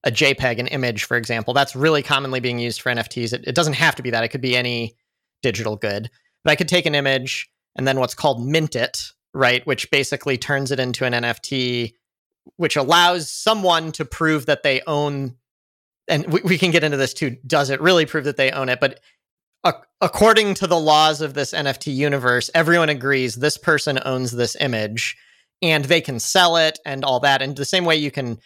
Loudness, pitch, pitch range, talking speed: -19 LUFS, 140 Hz, 125-155 Hz, 215 wpm